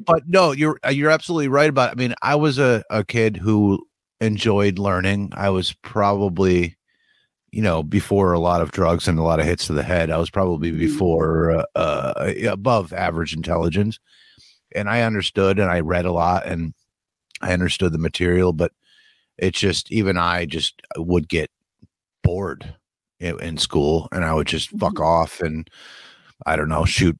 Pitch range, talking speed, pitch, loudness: 85-105 Hz, 180 wpm, 90 Hz, -20 LUFS